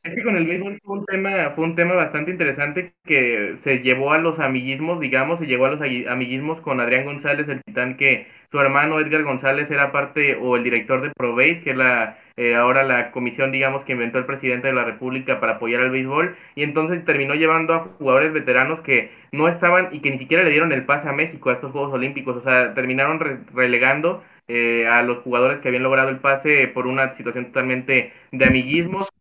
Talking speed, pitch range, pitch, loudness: 215 wpm, 130-160 Hz, 135 Hz, -19 LUFS